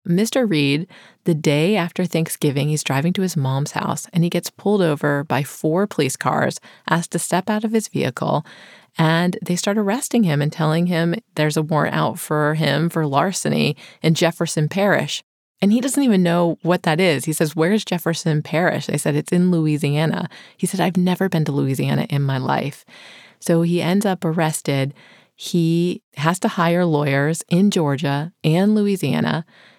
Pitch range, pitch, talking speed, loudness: 150-185 Hz, 165 Hz, 180 wpm, -19 LUFS